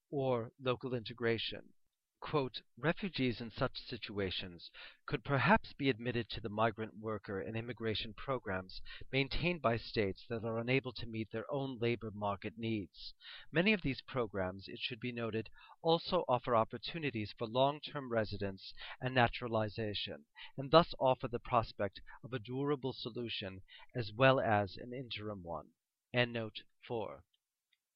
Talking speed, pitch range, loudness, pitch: 140 wpm, 110-130 Hz, -37 LUFS, 120 Hz